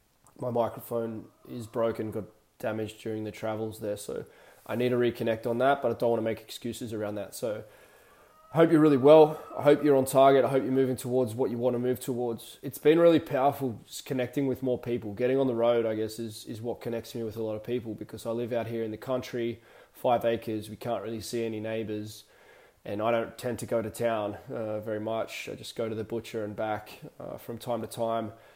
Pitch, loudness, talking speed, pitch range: 115 Hz, -28 LUFS, 235 wpm, 110-125 Hz